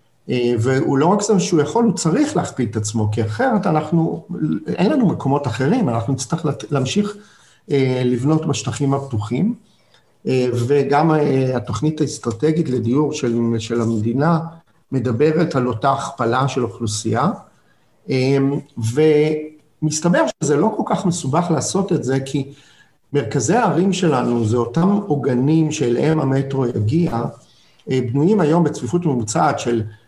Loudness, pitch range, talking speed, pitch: -18 LUFS, 125-160 Hz, 120 wpm, 140 Hz